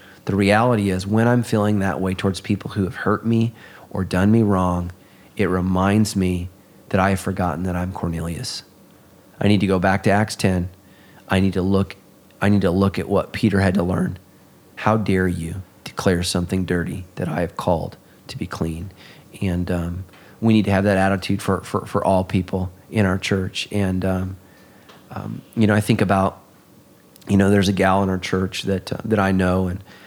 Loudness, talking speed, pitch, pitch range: -20 LUFS, 200 wpm, 95 Hz, 95-100 Hz